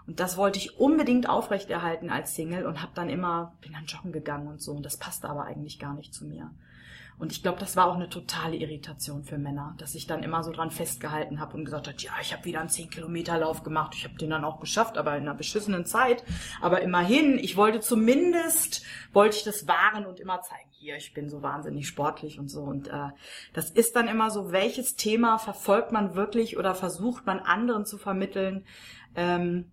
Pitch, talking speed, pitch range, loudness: 170 Hz, 220 wpm, 150-200 Hz, -28 LUFS